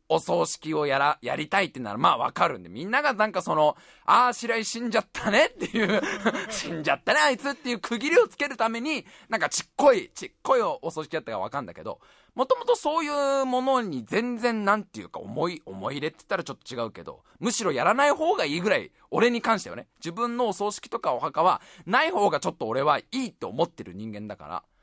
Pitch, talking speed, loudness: 230 Hz, 450 characters per minute, -25 LUFS